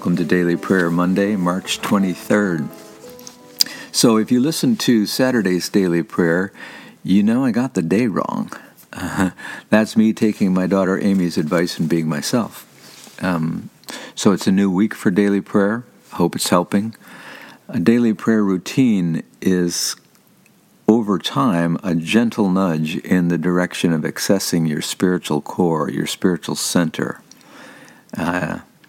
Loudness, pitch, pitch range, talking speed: -18 LUFS, 95 Hz, 90-110 Hz, 140 wpm